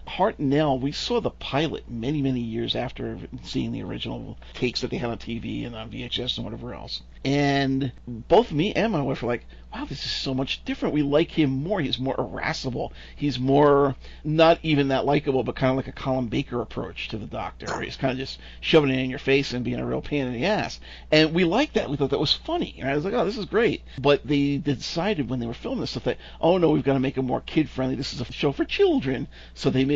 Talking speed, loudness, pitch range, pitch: 250 wpm, -25 LUFS, 125-145 Hz, 135 Hz